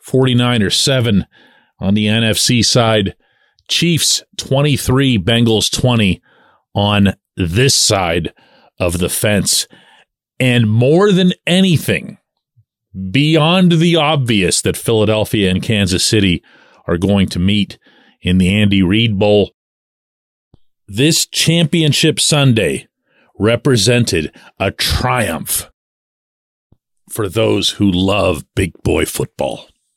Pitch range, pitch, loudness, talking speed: 100-135 Hz, 110 Hz, -14 LUFS, 100 wpm